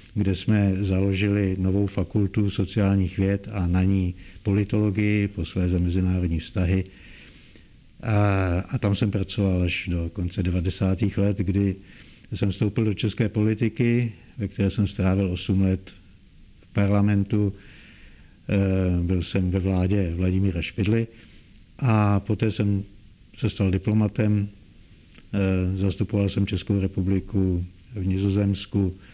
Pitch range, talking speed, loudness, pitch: 95-105 Hz, 115 wpm, -24 LUFS, 100 Hz